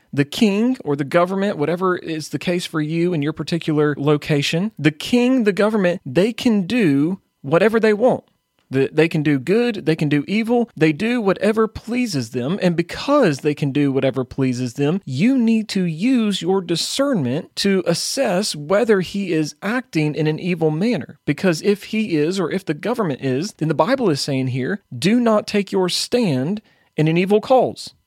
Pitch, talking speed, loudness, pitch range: 180 Hz, 185 wpm, -19 LUFS, 150-215 Hz